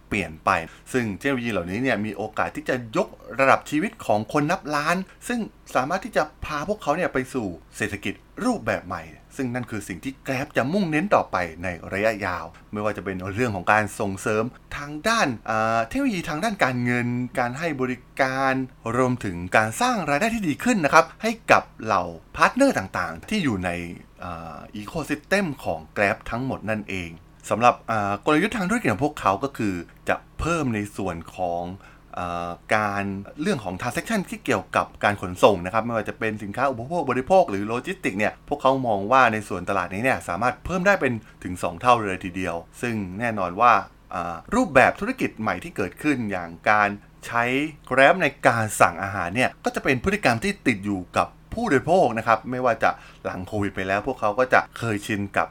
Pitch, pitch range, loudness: 120 Hz, 100-145 Hz, -24 LUFS